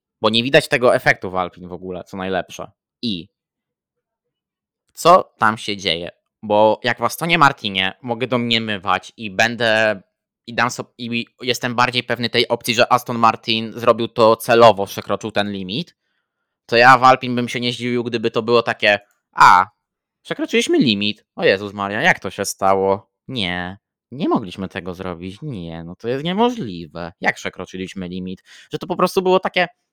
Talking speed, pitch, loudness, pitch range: 170 wpm, 115 Hz, -17 LUFS, 95-125 Hz